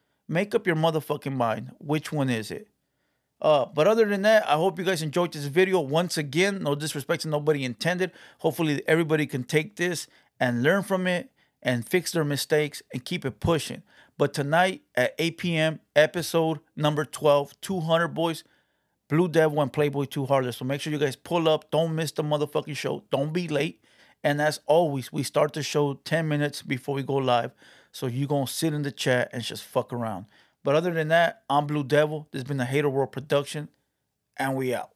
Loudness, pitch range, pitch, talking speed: -26 LUFS, 140-165 Hz, 150 Hz, 200 wpm